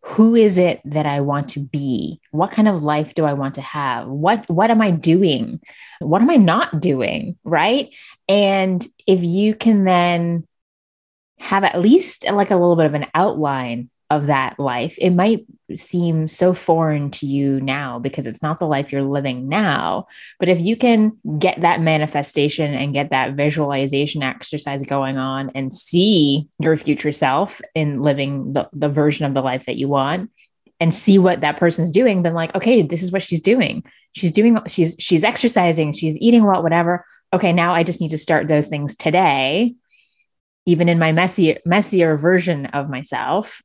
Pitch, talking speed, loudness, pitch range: 165 Hz, 185 wpm, -17 LUFS, 145-185 Hz